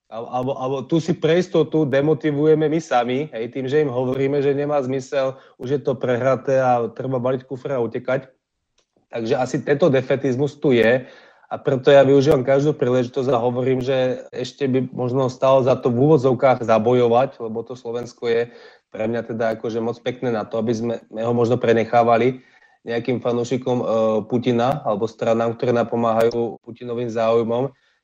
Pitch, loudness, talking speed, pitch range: 125 Hz, -20 LUFS, 165 wpm, 120-135 Hz